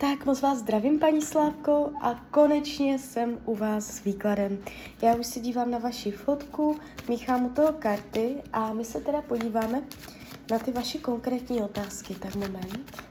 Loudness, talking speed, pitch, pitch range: -28 LUFS, 165 wpm, 245 Hz, 220-285 Hz